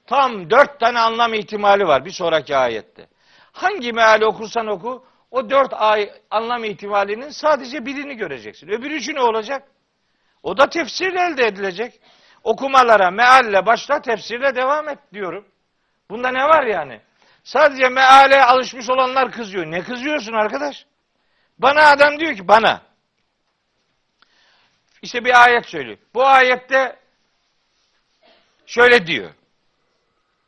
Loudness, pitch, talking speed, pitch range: -16 LUFS, 245 Hz, 120 wpm, 220-275 Hz